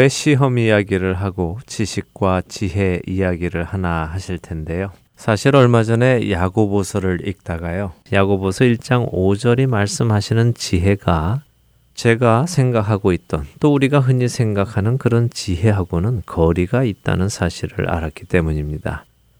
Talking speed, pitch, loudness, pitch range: 300 characters per minute, 100 Hz, -18 LUFS, 90-120 Hz